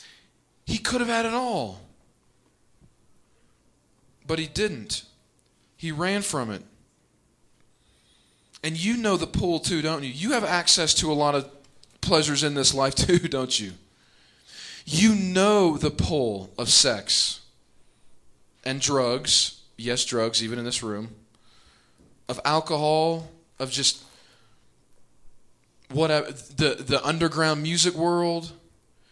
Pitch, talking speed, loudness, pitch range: 150 Hz, 120 wpm, -23 LUFS, 130-170 Hz